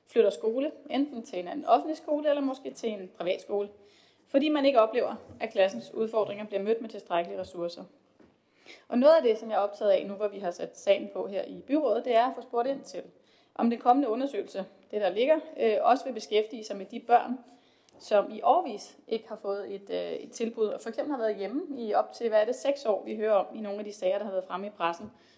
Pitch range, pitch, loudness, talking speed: 200-265 Hz, 225 Hz, -29 LUFS, 240 wpm